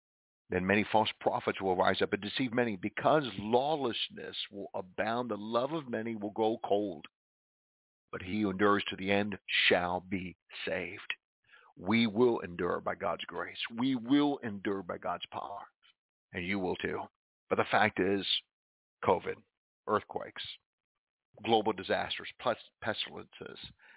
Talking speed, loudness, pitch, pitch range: 140 wpm, -33 LUFS, 105 Hz, 100-120 Hz